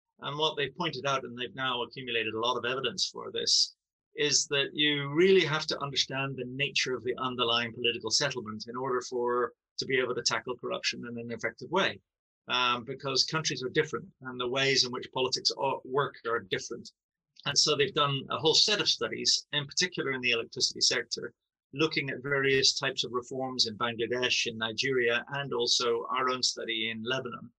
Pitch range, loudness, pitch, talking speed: 120-145 Hz, -29 LUFS, 130 Hz, 190 wpm